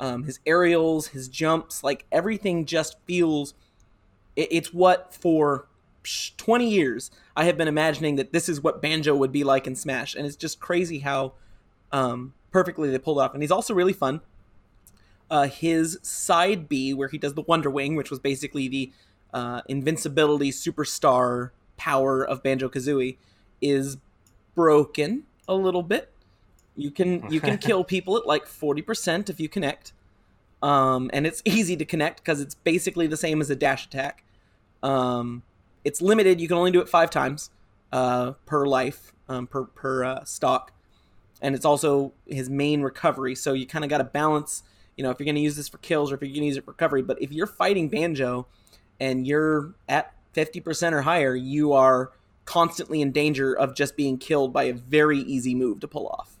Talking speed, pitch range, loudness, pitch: 185 wpm, 130-160 Hz, -24 LUFS, 140 Hz